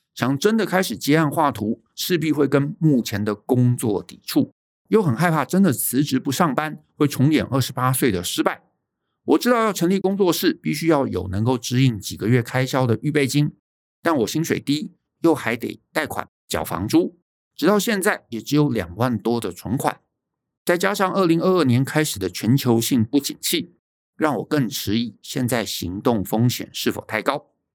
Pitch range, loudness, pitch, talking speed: 115-160 Hz, -21 LUFS, 135 Hz, 270 characters per minute